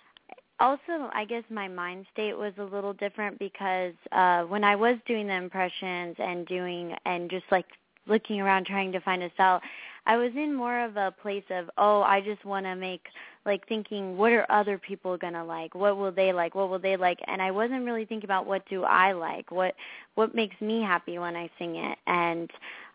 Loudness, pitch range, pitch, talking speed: -28 LUFS, 180-210 Hz, 195 Hz, 210 wpm